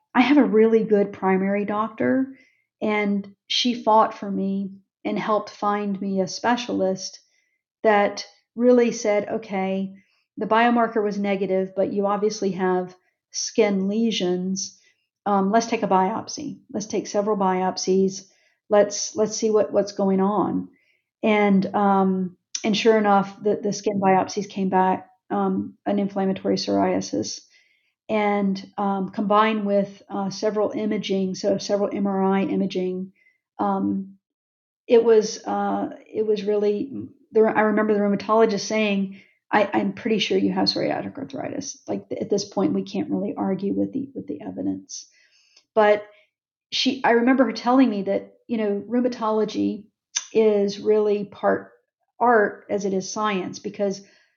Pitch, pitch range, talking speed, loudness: 205 Hz, 190-220 Hz, 140 wpm, -22 LUFS